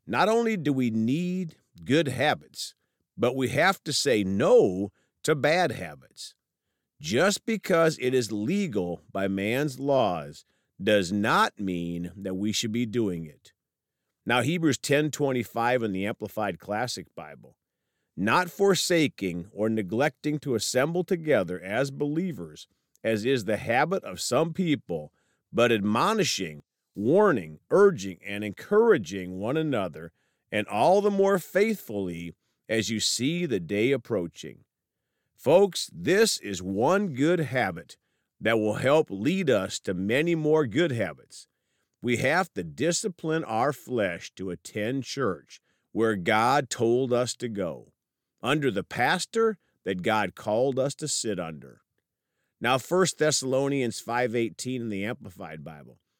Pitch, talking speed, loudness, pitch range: 125 Hz, 135 wpm, -26 LUFS, 105-160 Hz